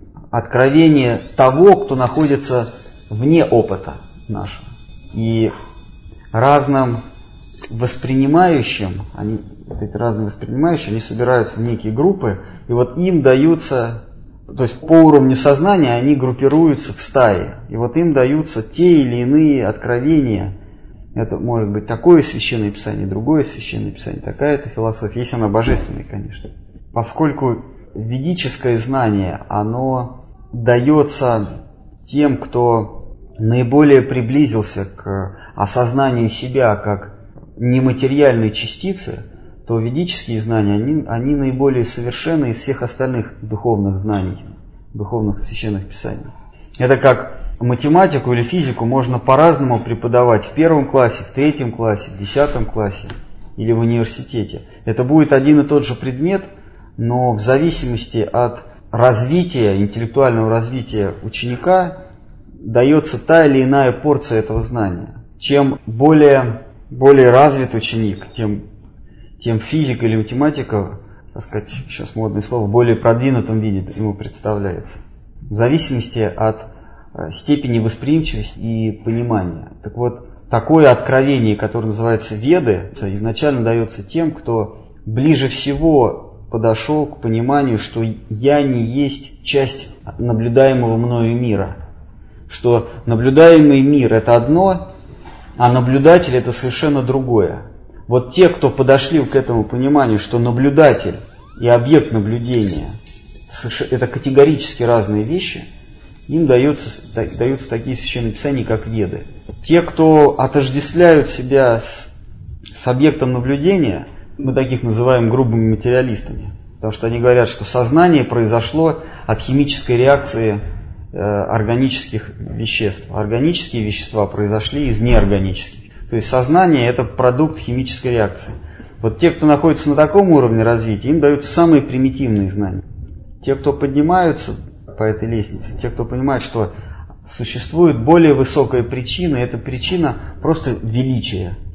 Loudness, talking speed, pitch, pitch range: -15 LUFS, 120 wpm, 120 Hz, 110-140 Hz